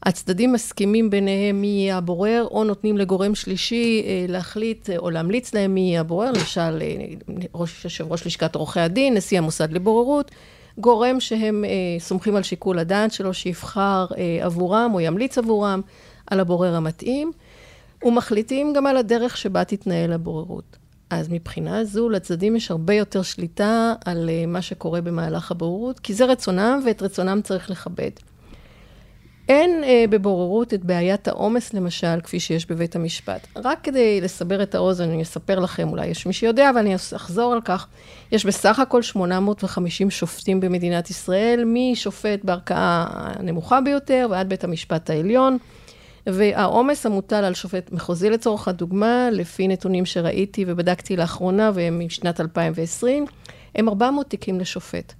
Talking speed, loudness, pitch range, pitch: 145 wpm, -21 LUFS, 175-225 Hz, 195 Hz